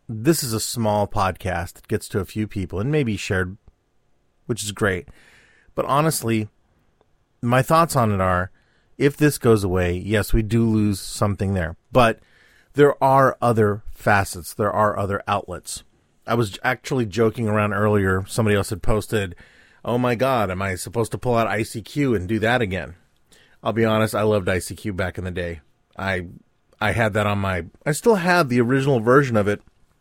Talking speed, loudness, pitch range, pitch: 180 wpm, -21 LUFS, 95-120 Hz, 105 Hz